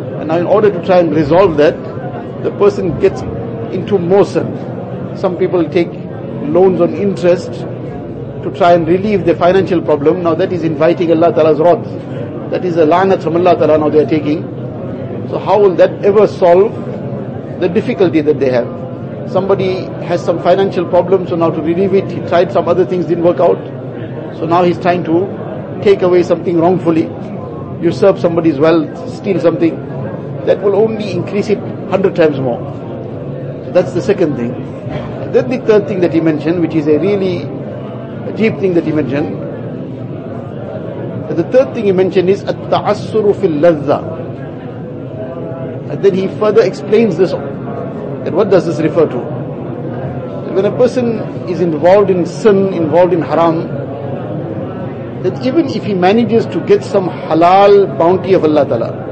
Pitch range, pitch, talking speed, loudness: 150-185 Hz, 170 Hz, 165 wpm, -13 LUFS